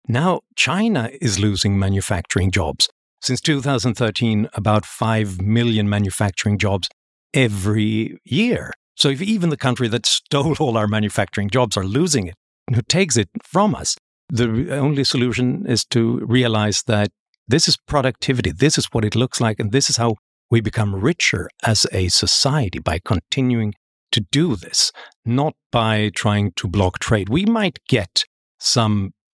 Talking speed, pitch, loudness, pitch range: 155 wpm, 115 Hz, -19 LUFS, 105-135 Hz